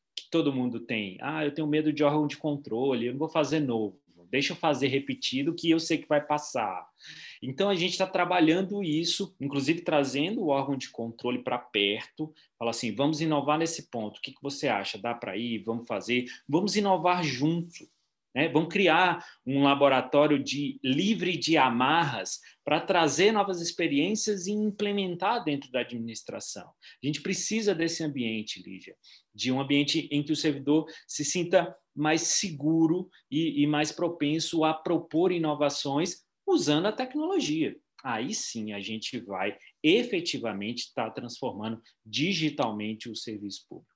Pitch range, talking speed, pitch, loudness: 130-170 Hz, 160 wpm, 150 Hz, -28 LUFS